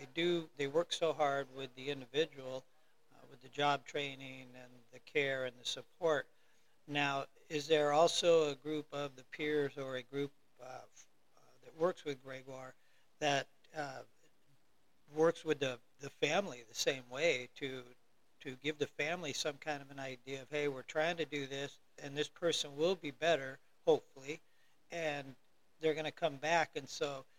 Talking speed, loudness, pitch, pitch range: 175 wpm, -37 LUFS, 145 Hz, 135-155 Hz